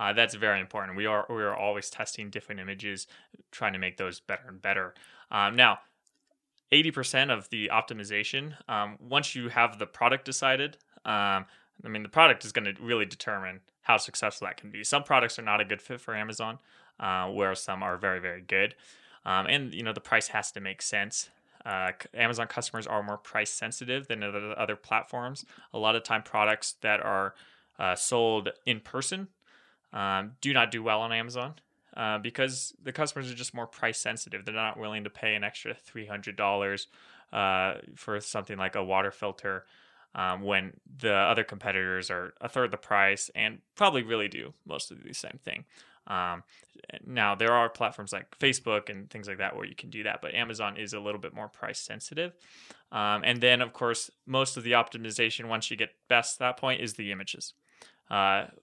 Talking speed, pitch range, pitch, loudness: 200 wpm, 100-125 Hz, 110 Hz, -29 LUFS